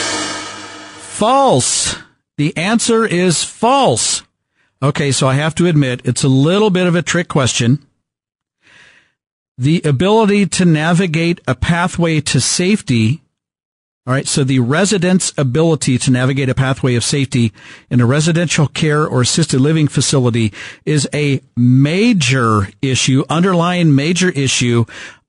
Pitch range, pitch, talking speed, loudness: 130-175 Hz, 145 Hz, 130 wpm, -14 LUFS